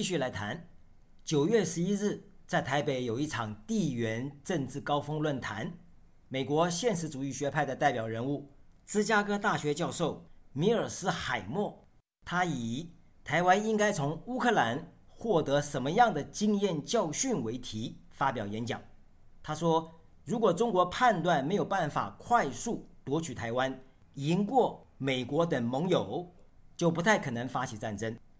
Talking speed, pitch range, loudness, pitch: 230 characters per minute, 130-180 Hz, -31 LUFS, 145 Hz